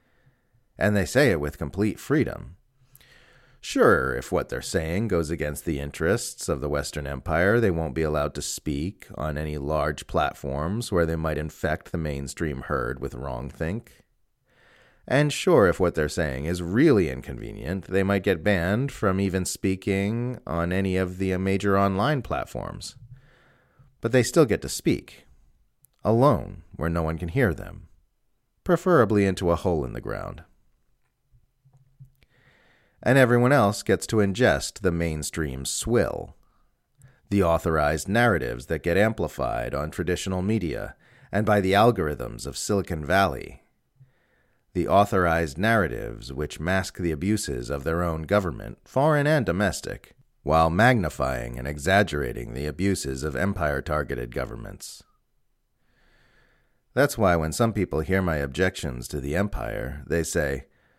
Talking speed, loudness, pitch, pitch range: 145 wpm, -25 LUFS, 90 Hz, 75-110 Hz